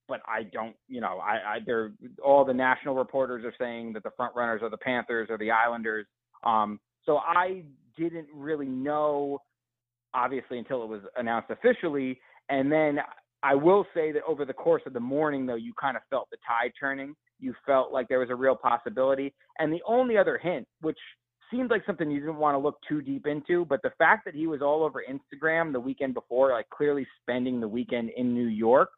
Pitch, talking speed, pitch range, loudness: 135 Hz, 210 wpm, 120-155 Hz, -28 LUFS